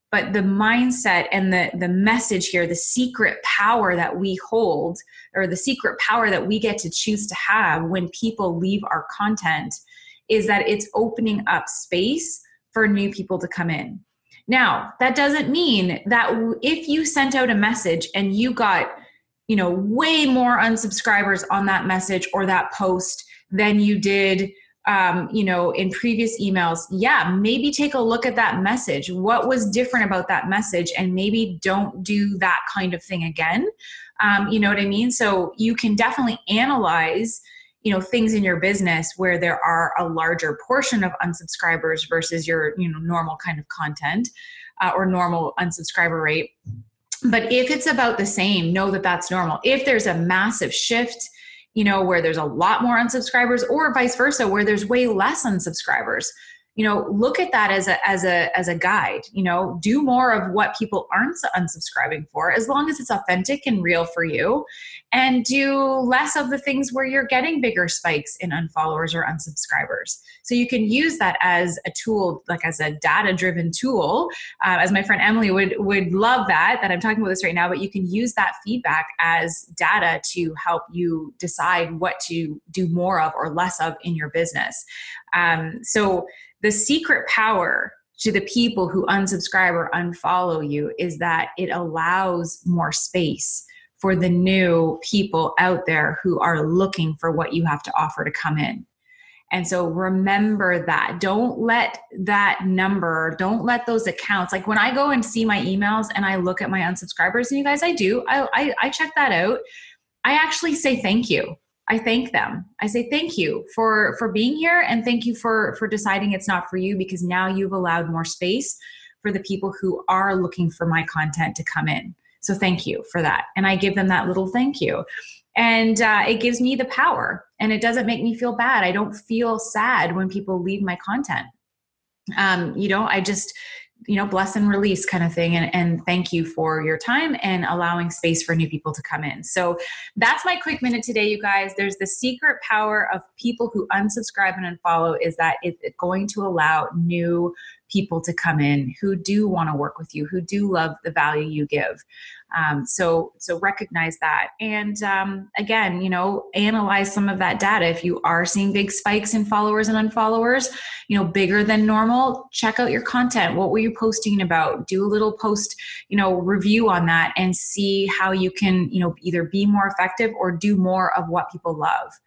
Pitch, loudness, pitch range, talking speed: 195 Hz, -20 LUFS, 175-230 Hz, 195 wpm